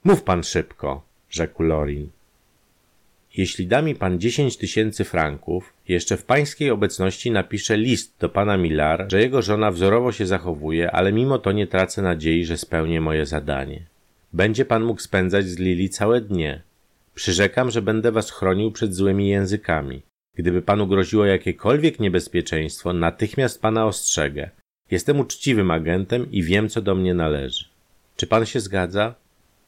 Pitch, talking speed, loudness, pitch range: 95 Hz, 150 wpm, -21 LUFS, 85-110 Hz